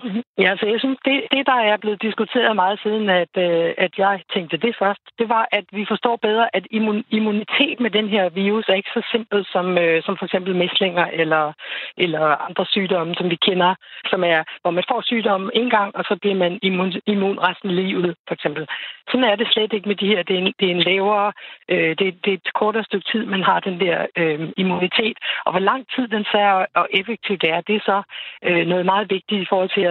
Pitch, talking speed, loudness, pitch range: 195 Hz, 220 wpm, -19 LUFS, 180-215 Hz